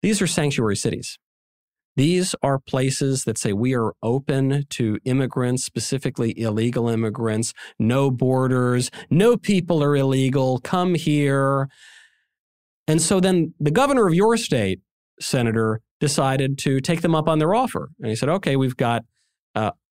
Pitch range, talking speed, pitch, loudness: 120-160 Hz, 150 wpm, 135 Hz, -21 LUFS